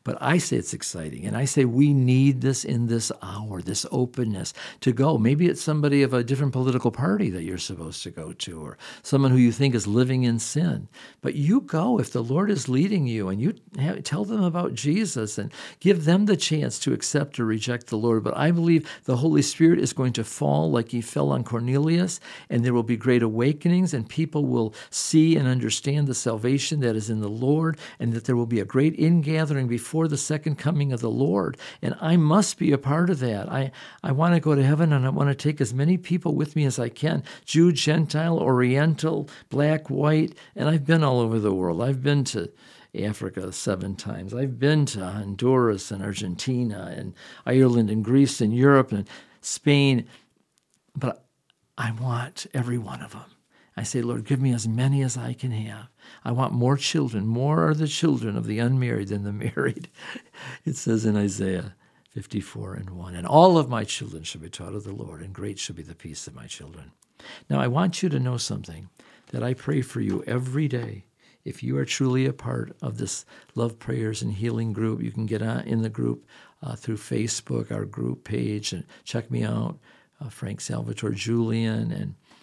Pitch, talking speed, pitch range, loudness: 125 Hz, 205 wpm, 110-150 Hz, -24 LUFS